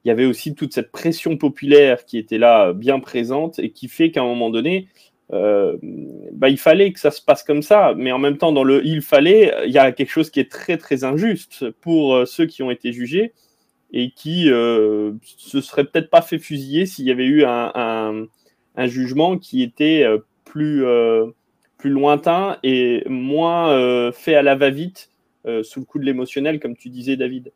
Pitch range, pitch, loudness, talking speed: 125-165 Hz, 140 Hz, -17 LUFS, 210 wpm